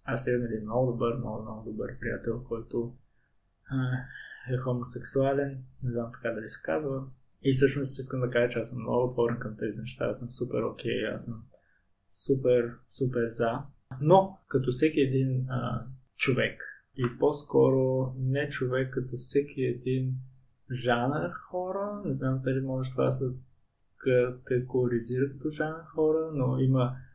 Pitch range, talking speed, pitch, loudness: 120-135 Hz, 155 wpm, 125 Hz, -30 LUFS